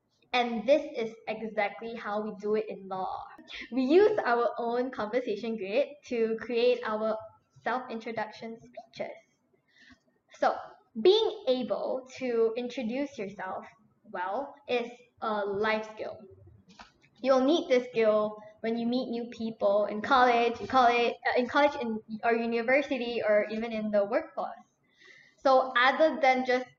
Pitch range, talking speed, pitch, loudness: 220-260 Hz, 130 wpm, 235 Hz, -29 LUFS